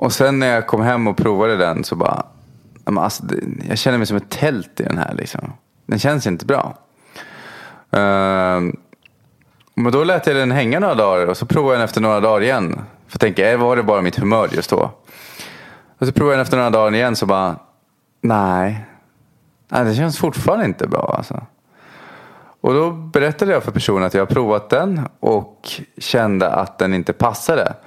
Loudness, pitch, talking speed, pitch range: -17 LUFS, 115 Hz, 190 wpm, 100-130 Hz